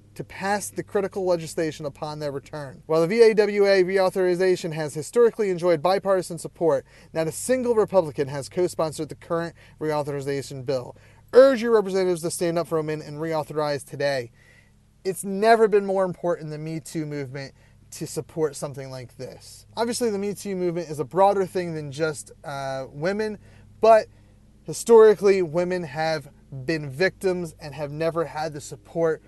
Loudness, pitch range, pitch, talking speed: -23 LUFS, 145-190 Hz, 160 Hz, 160 wpm